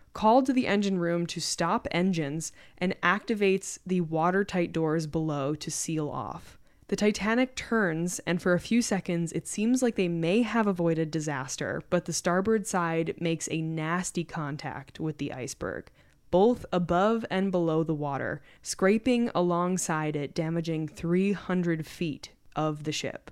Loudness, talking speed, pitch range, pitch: -28 LUFS, 150 wpm, 160-195 Hz, 170 Hz